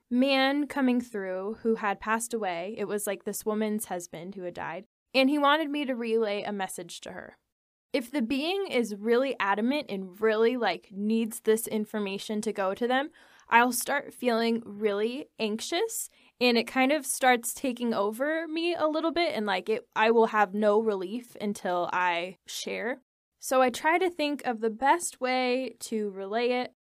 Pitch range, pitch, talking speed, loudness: 210-260 Hz, 230 Hz, 180 wpm, -28 LUFS